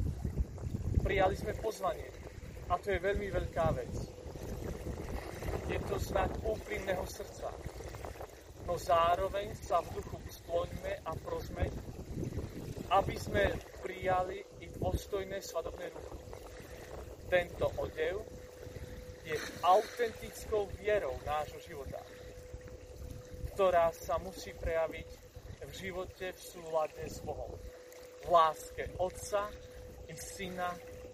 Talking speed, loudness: 100 wpm, -36 LUFS